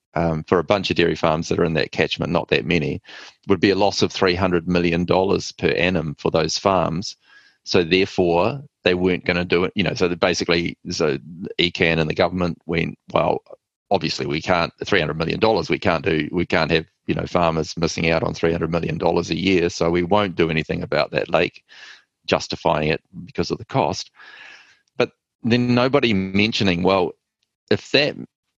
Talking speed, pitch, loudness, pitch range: 185 wpm, 90 Hz, -20 LUFS, 85-95 Hz